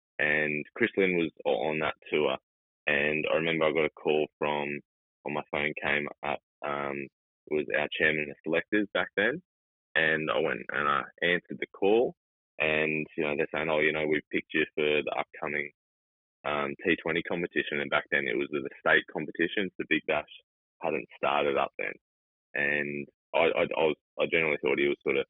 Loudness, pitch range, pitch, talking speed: -29 LUFS, 70-80 Hz, 75 Hz, 195 wpm